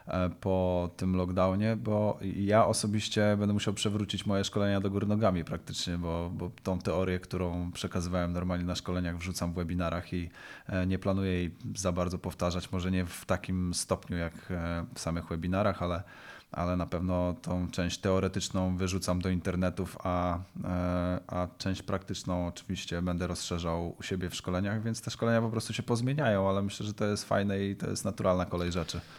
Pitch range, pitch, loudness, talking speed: 90-100 Hz, 90 Hz, -32 LUFS, 170 wpm